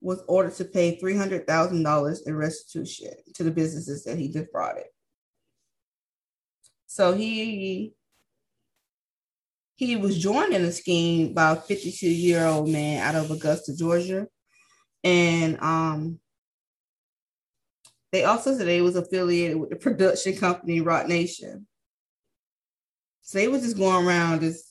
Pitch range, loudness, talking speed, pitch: 160-190 Hz, -24 LUFS, 125 wpm, 175 Hz